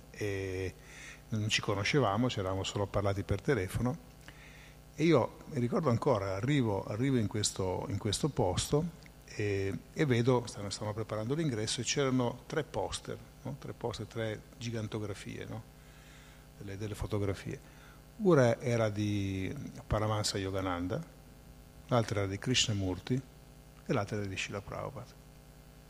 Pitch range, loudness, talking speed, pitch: 105-140 Hz, -33 LUFS, 130 wpm, 120 Hz